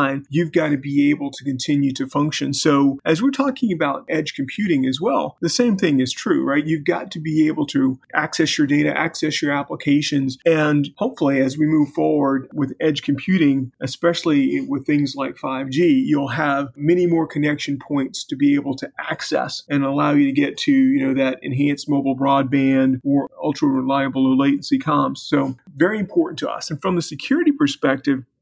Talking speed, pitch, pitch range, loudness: 190 wpm, 145 Hz, 140-170 Hz, -19 LUFS